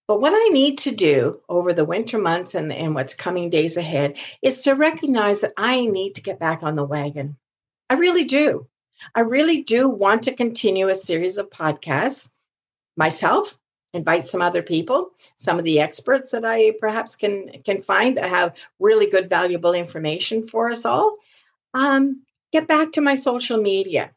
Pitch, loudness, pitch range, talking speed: 205 Hz, -19 LUFS, 175-270 Hz, 180 wpm